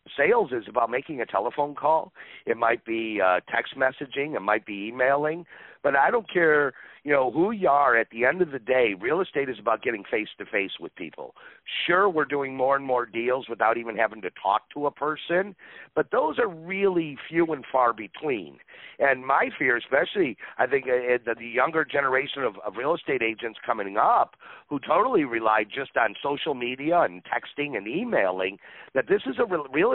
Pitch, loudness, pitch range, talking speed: 135 Hz, -25 LUFS, 115-155 Hz, 200 wpm